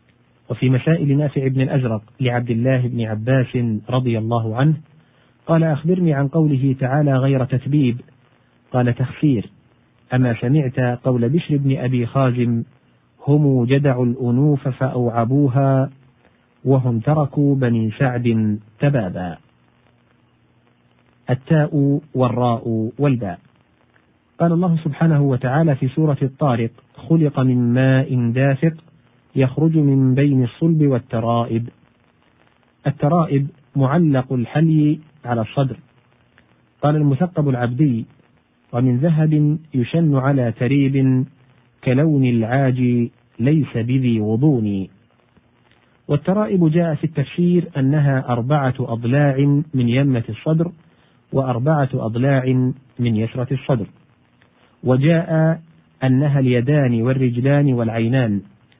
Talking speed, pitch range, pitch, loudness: 95 wpm, 120-145 Hz, 130 Hz, -18 LUFS